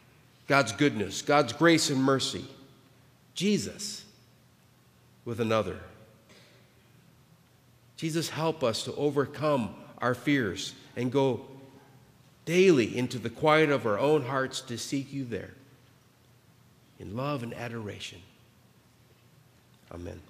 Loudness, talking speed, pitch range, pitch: -28 LUFS, 105 wpm, 120-145 Hz, 130 Hz